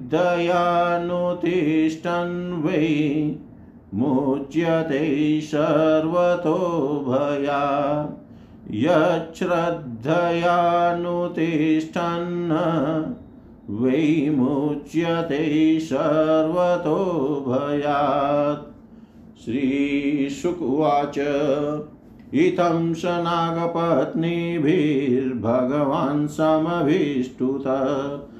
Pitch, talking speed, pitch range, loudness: 155 Hz, 35 wpm, 145-170 Hz, -22 LUFS